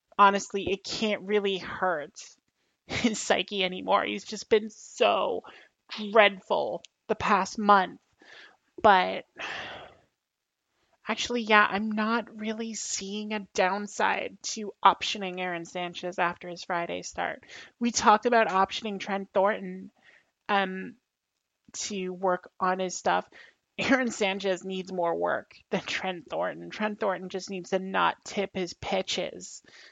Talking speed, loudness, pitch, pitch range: 125 wpm, -28 LUFS, 195 Hz, 185-215 Hz